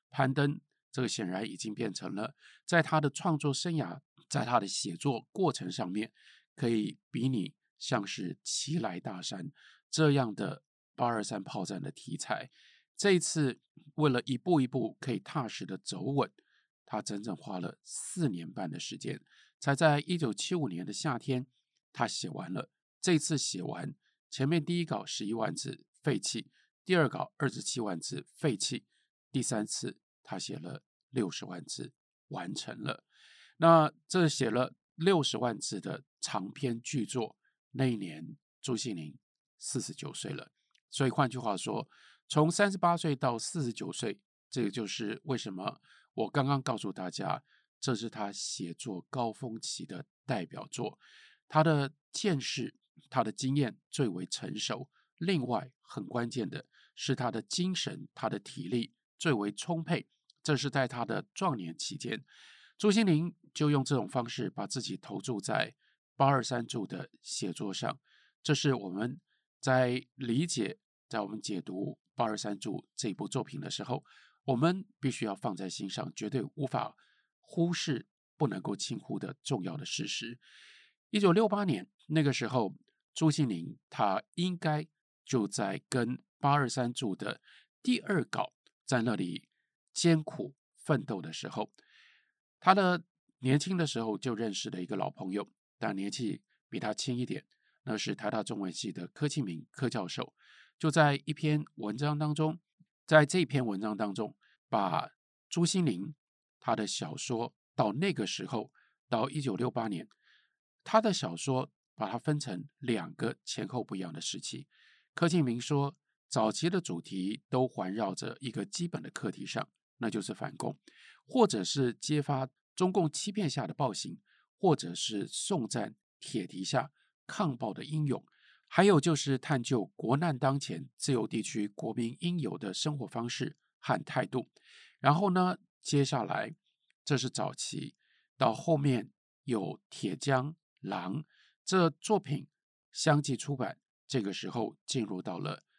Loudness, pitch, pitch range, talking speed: -33 LUFS, 145 Hz, 125-165 Hz, 225 characters per minute